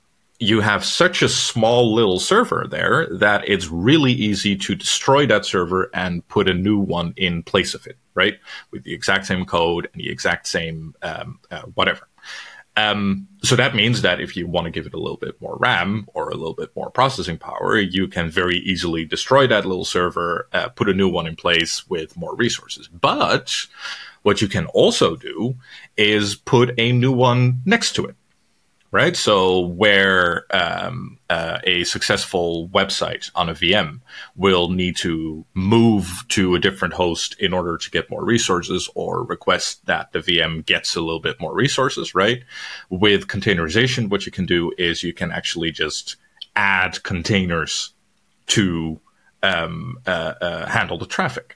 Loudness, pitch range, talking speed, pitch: -19 LUFS, 85-105 Hz, 175 wpm, 95 Hz